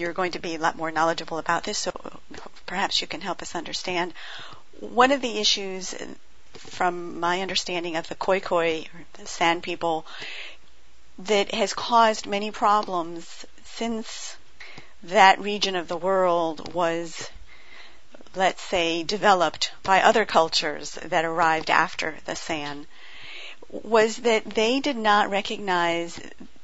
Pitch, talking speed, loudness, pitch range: 180 Hz, 135 wpm, -24 LUFS, 170-210 Hz